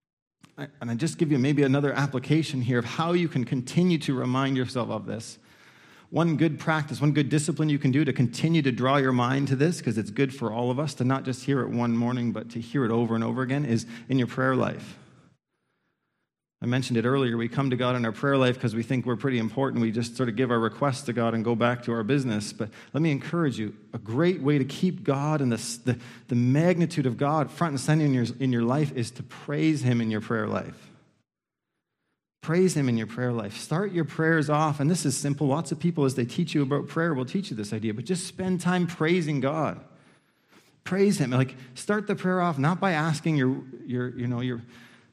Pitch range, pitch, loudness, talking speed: 120-155 Hz, 135 Hz, -26 LUFS, 240 wpm